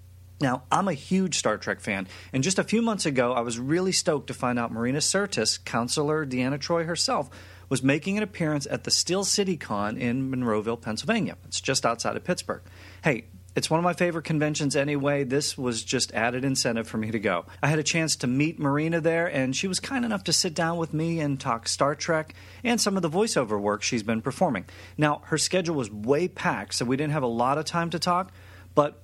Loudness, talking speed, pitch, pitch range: -26 LUFS, 225 wpm, 140 Hz, 115-170 Hz